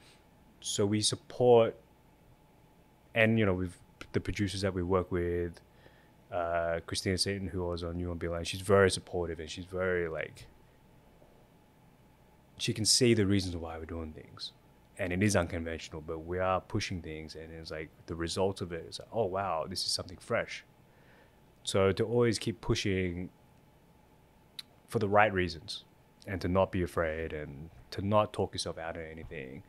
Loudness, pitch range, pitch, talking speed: -32 LUFS, 85-100 Hz, 90 Hz, 170 wpm